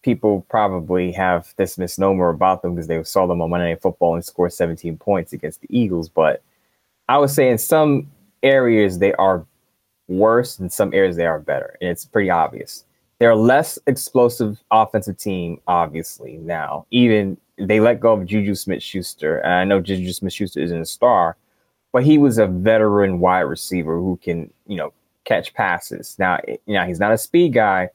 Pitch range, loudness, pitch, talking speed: 90-110 Hz, -18 LUFS, 95 Hz, 185 wpm